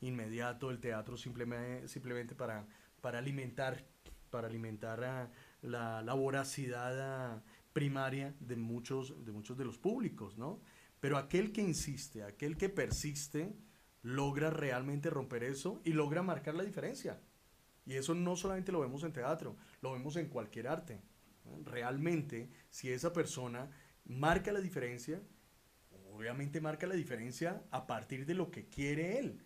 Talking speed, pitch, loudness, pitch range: 140 wpm, 135 Hz, -41 LUFS, 120-160 Hz